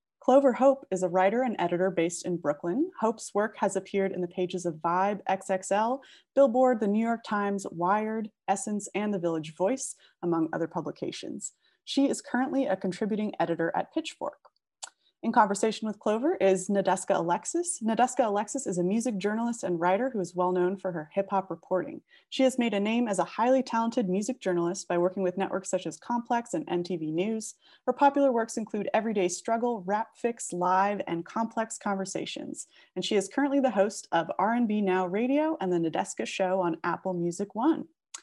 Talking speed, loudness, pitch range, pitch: 185 wpm, -28 LUFS, 185-240 Hz, 205 Hz